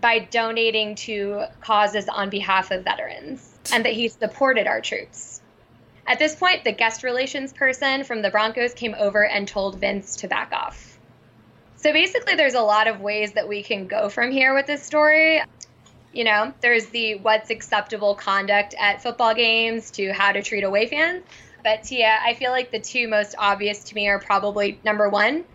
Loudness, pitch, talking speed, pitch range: -21 LUFS, 220 Hz, 185 wpm, 205-245 Hz